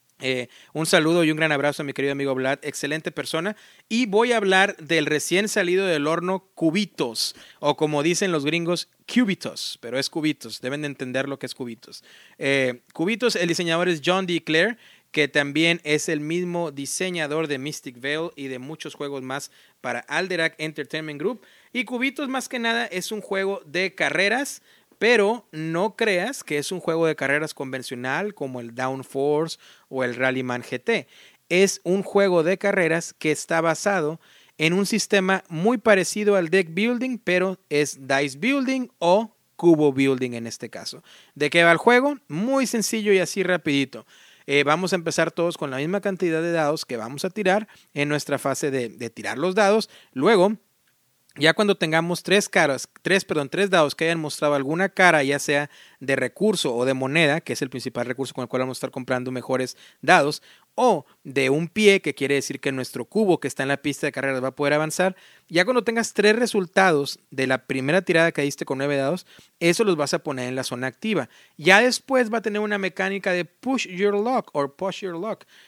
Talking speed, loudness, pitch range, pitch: 195 wpm, -23 LUFS, 140-195 Hz, 165 Hz